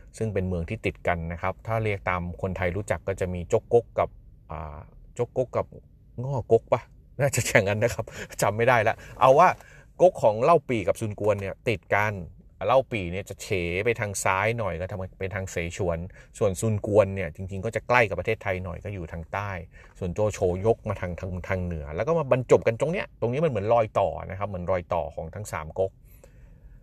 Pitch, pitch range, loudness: 100 Hz, 90-115 Hz, -26 LUFS